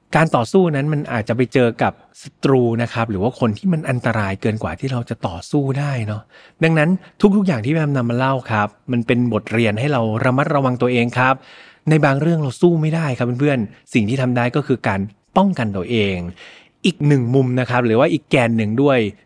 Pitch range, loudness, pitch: 115-150 Hz, -18 LUFS, 125 Hz